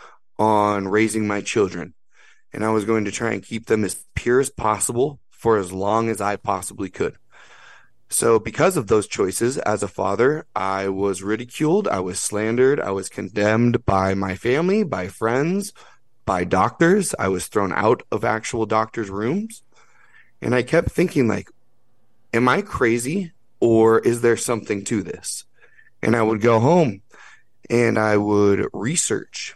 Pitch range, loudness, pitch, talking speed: 100-125 Hz, -21 LUFS, 110 Hz, 160 wpm